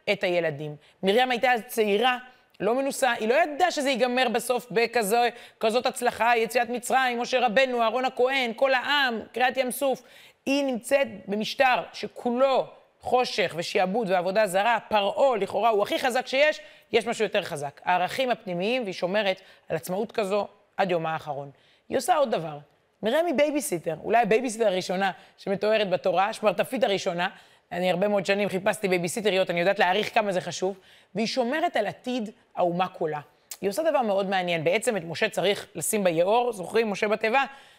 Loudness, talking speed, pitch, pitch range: -25 LUFS, 160 wpm, 220 Hz, 185-250 Hz